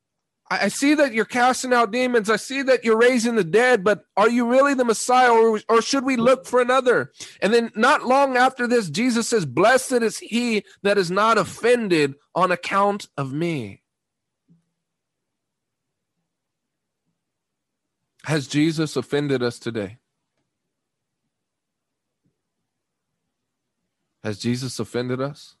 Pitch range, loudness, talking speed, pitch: 165-245 Hz, -20 LUFS, 130 wpm, 220 Hz